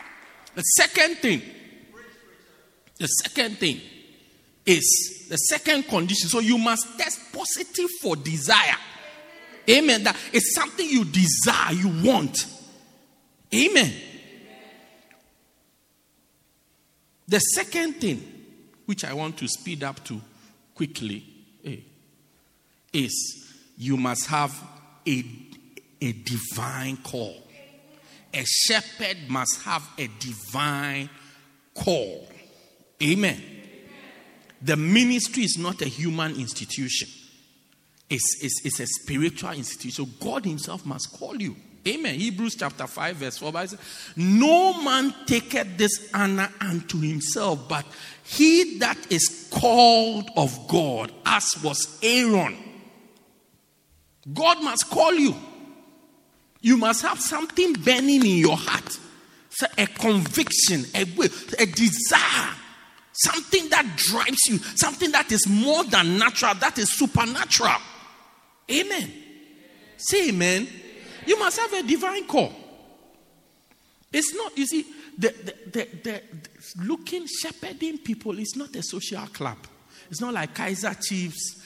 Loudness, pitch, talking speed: -22 LUFS, 210 Hz, 115 wpm